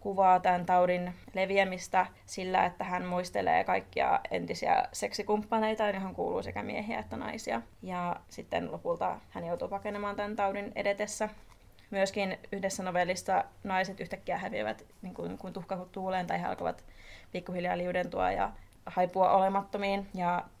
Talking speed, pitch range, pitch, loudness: 130 wpm, 180-200 Hz, 190 Hz, -32 LUFS